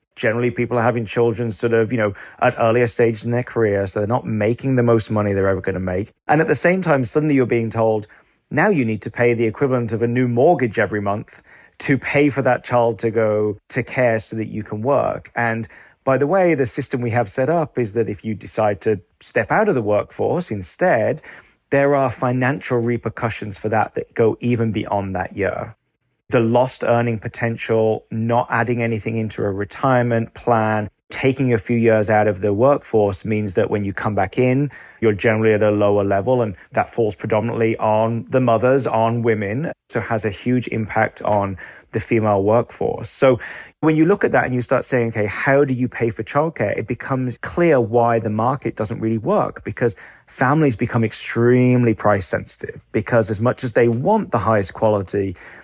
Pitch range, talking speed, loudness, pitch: 110-125 Hz, 205 wpm, -19 LUFS, 115 Hz